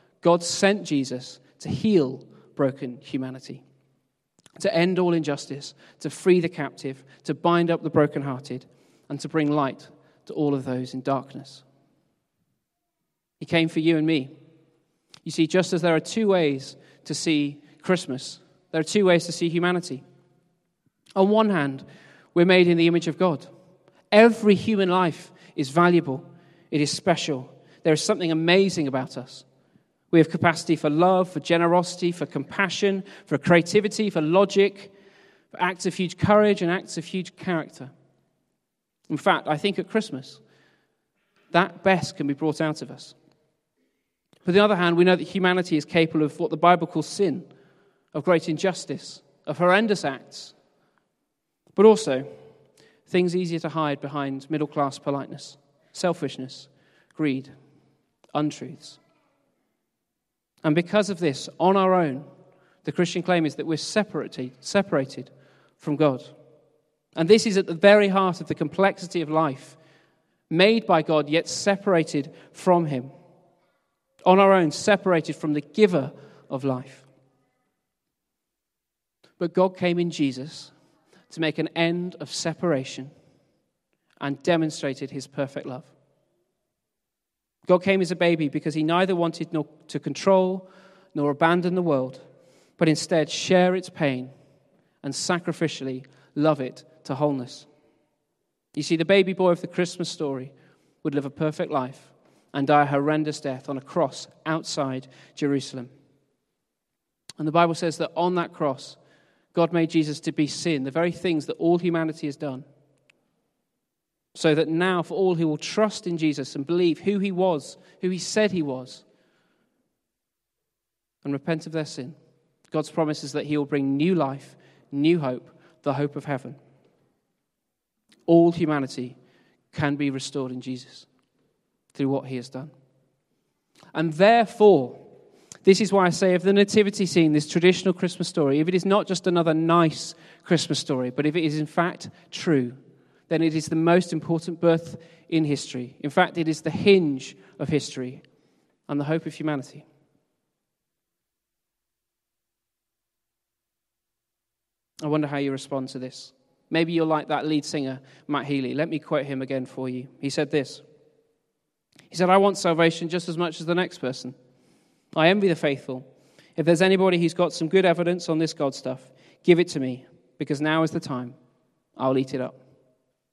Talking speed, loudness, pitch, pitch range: 160 wpm, -23 LUFS, 160 Hz, 140-175 Hz